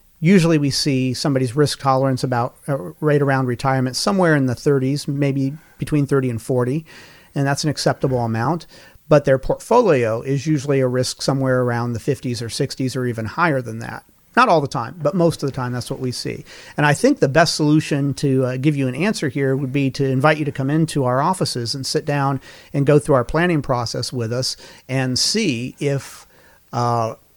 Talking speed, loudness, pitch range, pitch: 205 wpm, -19 LUFS, 130-150 Hz, 135 Hz